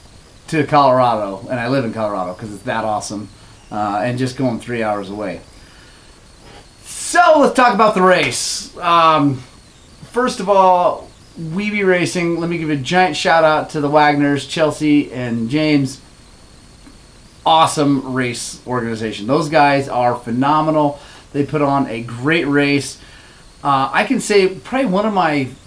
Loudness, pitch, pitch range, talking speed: -16 LUFS, 140 Hz, 120-165 Hz, 150 wpm